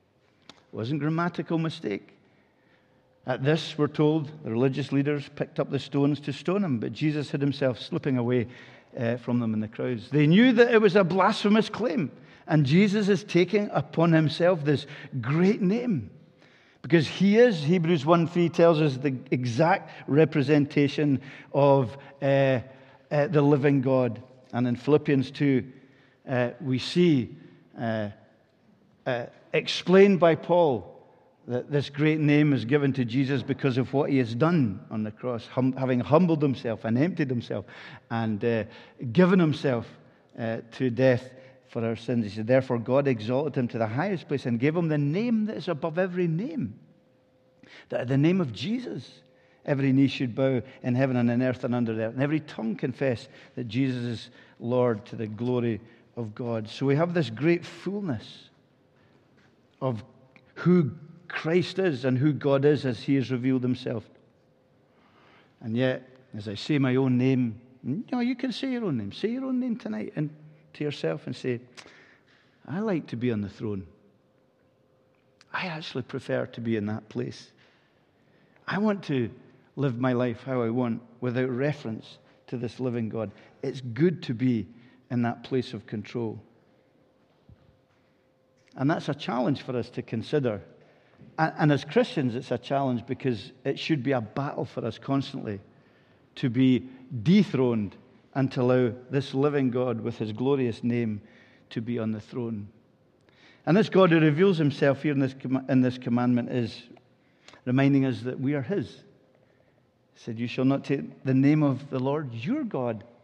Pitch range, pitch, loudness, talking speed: 125-150 Hz, 130 Hz, -26 LUFS, 170 wpm